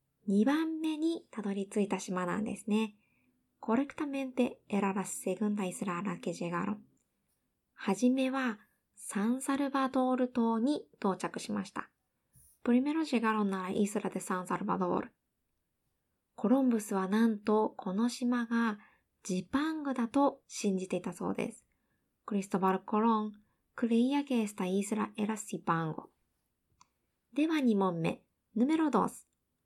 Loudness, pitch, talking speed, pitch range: -33 LUFS, 215 Hz, 305 characters per minute, 195-255 Hz